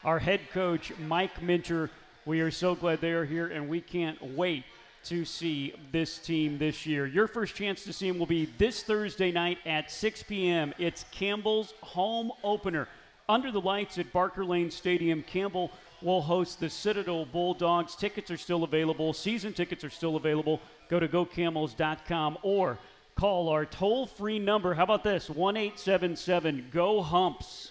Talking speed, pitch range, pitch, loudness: 170 wpm, 160-195 Hz, 175 Hz, -30 LUFS